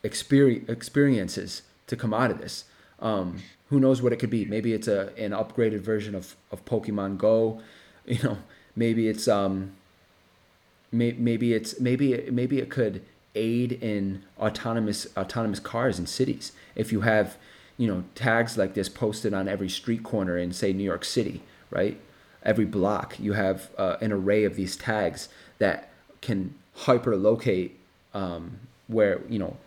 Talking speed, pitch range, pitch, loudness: 160 wpm, 95-115 Hz, 105 Hz, -27 LUFS